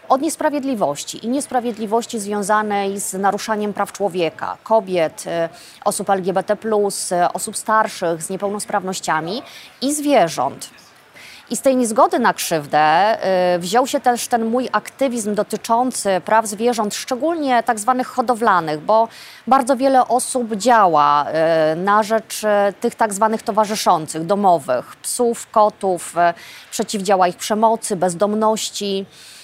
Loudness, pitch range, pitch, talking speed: -18 LUFS, 190-240 Hz, 215 Hz, 110 wpm